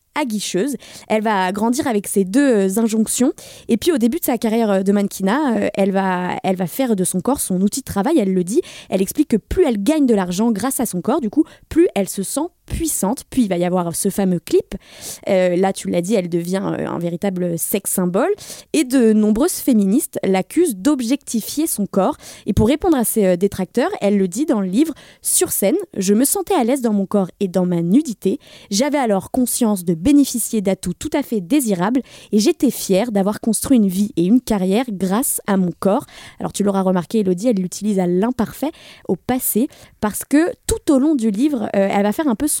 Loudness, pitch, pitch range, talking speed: -18 LUFS, 215 Hz, 195-270 Hz, 215 wpm